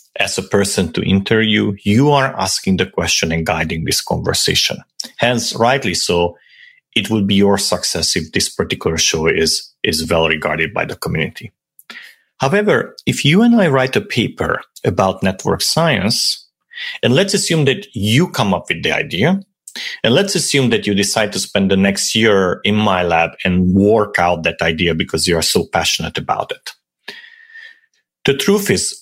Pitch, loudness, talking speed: 105 Hz, -15 LUFS, 170 wpm